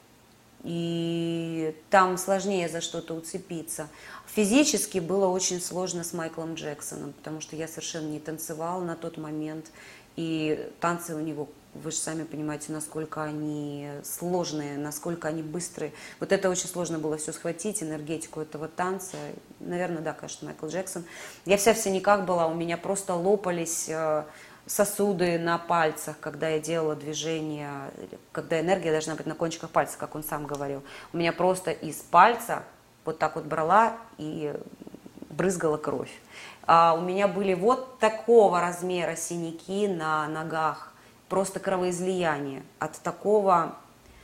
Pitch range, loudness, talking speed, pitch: 155-180 Hz, -28 LUFS, 140 wpm, 165 Hz